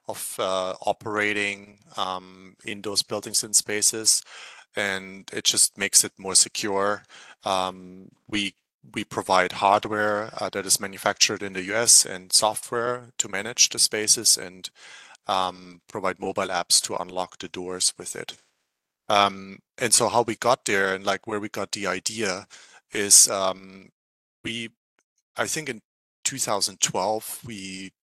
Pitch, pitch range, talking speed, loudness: 100 Hz, 95-105 Hz, 145 wpm, -22 LUFS